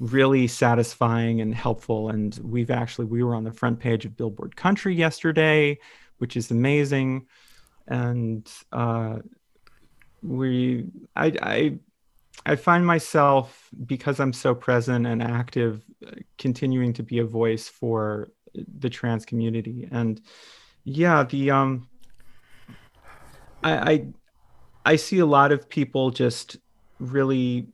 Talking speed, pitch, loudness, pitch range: 125 wpm, 125 Hz, -23 LUFS, 115-135 Hz